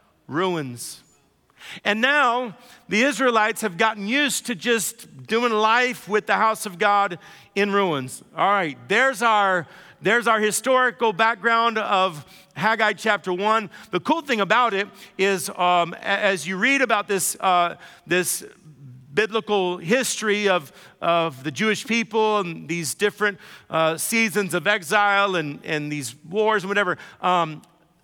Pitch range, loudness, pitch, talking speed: 180-225 Hz, -21 LUFS, 205 Hz, 140 wpm